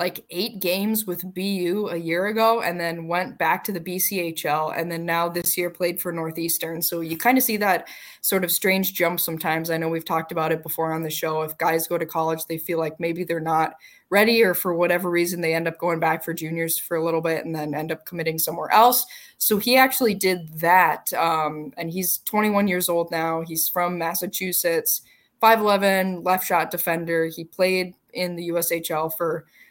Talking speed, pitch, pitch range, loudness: 210 wpm, 170 Hz, 165-185 Hz, -22 LUFS